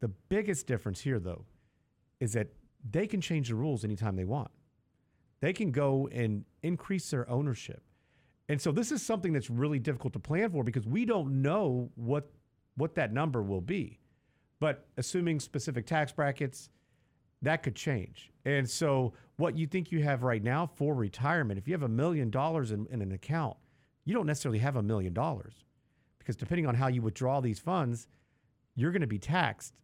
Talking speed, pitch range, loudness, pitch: 185 wpm, 120-155 Hz, -33 LUFS, 135 Hz